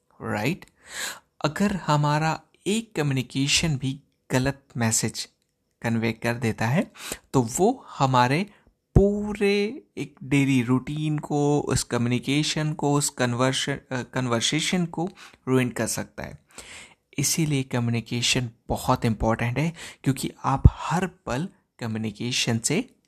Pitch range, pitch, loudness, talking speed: 120-155 Hz, 135 Hz, -25 LUFS, 110 wpm